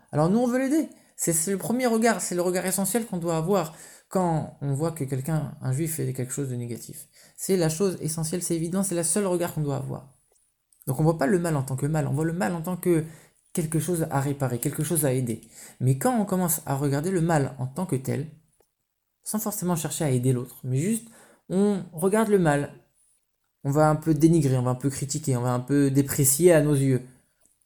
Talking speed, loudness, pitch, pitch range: 240 wpm, -25 LUFS, 160 Hz, 140-180 Hz